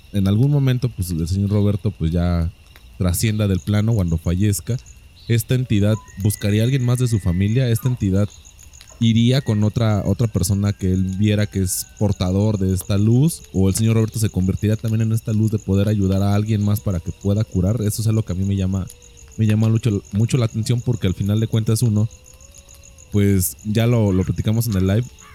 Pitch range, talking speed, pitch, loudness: 95-110 Hz, 205 wpm, 105 Hz, -19 LUFS